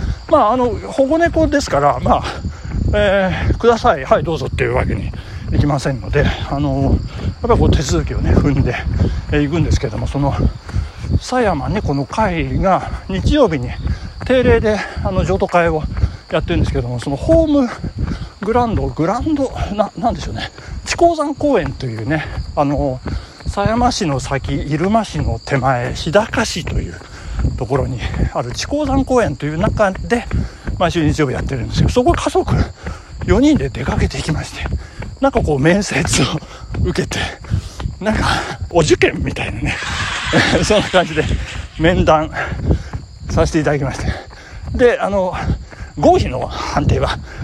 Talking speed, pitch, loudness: 300 characters per minute, 165 Hz, -17 LUFS